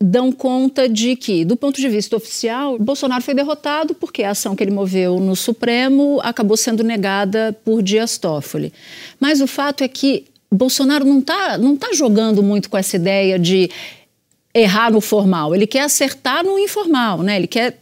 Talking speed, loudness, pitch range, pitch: 180 wpm, -16 LUFS, 205-275 Hz, 235 Hz